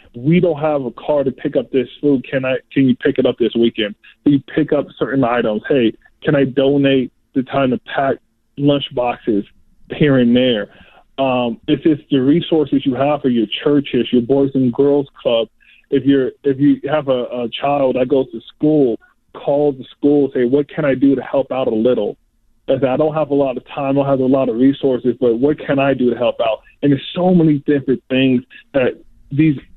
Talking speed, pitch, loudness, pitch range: 220 wpm, 135 Hz, -16 LUFS, 125-145 Hz